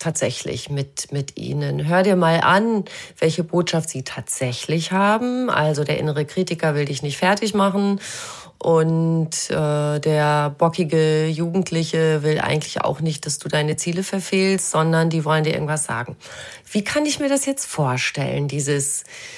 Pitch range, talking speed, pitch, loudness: 150-190 Hz, 155 wpm, 160 Hz, -20 LUFS